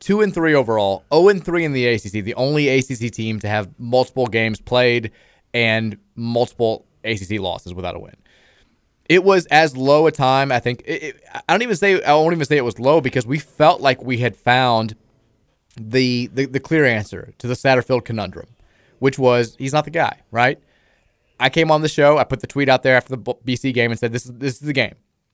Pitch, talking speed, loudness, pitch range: 125 Hz, 220 wpm, -18 LUFS, 115-140 Hz